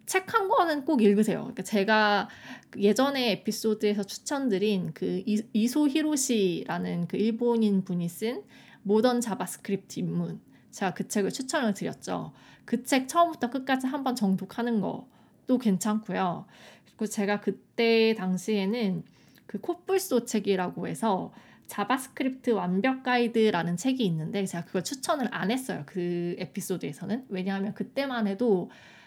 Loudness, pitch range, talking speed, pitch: -28 LUFS, 195-250 Hz, 305 characters per minute, 215 Hz